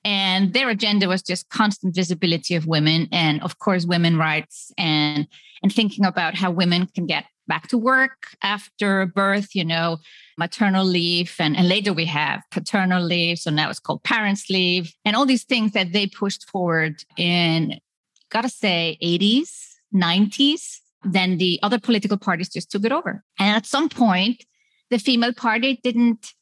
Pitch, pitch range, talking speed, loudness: 190 Hz, 175-220 Hz, 170 wpm, -20 LUFS